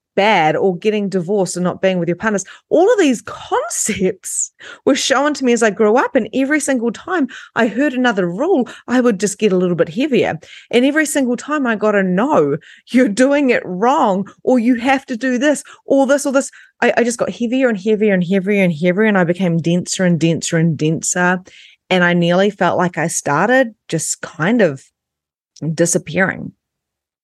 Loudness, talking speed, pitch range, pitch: -16 LUFS, 195 wpm, 180-255 Hz, 210 Hz